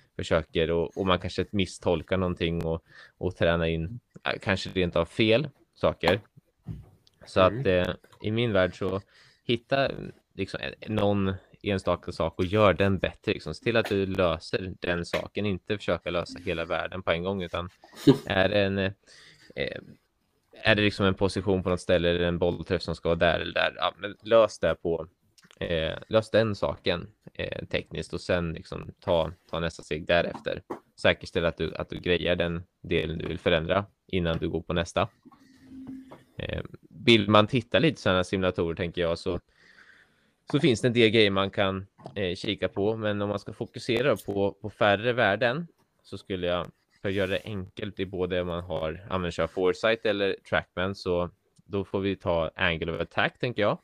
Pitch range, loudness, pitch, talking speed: 90-105 Hz, -27 LUFS, 95 Hz, 180 wpm